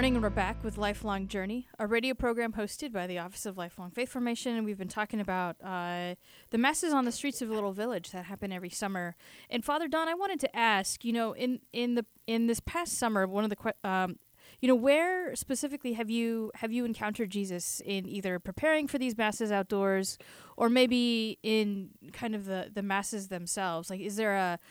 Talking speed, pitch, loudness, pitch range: 210 wpm, 220 Hz, -32 LUFS, 195-240 Hz